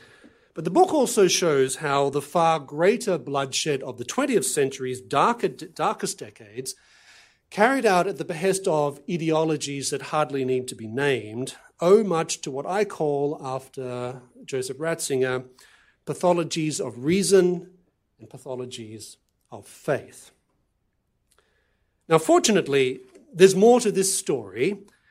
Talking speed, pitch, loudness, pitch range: 125 wpm, 155 Hz, -23 LUFS, 130-190 Hz